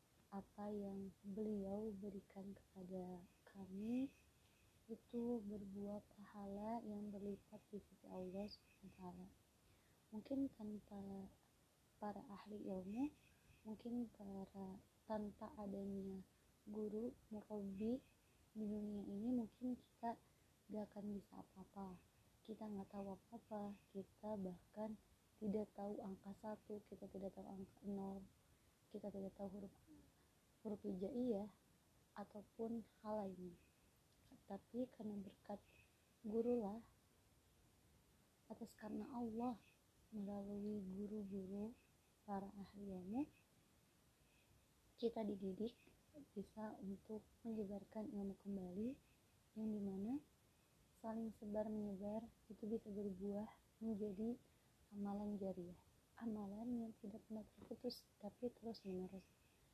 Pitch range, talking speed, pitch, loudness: 195-220 Hz, 100 wpm, 205 Hz, -51 LUFS